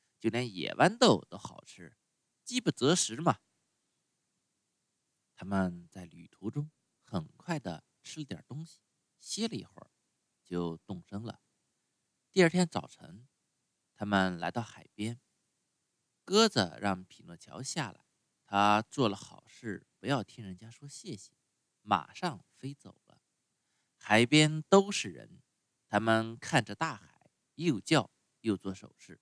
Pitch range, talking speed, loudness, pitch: 100-150 Hz, 185 characters per minute, -31 LUFS, 115 Hz